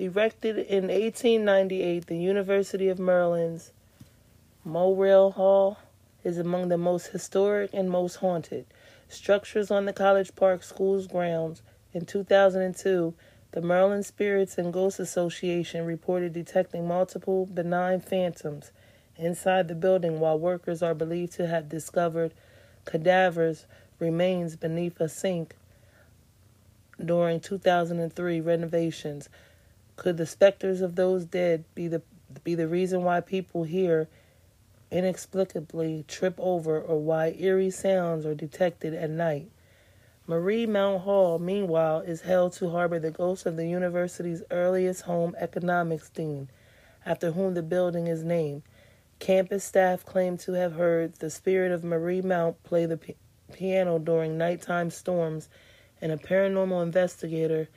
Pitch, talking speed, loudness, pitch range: 175 Hz, 130 wpm, -27 LUFS, 160-185 Hz